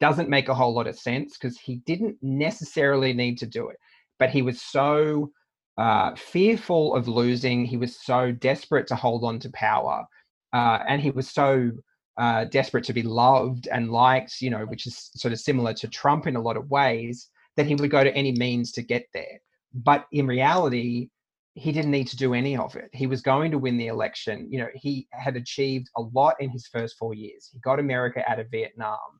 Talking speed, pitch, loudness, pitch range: 215 wpm, 130 Hz, -24 LUFS, 120-140 Hz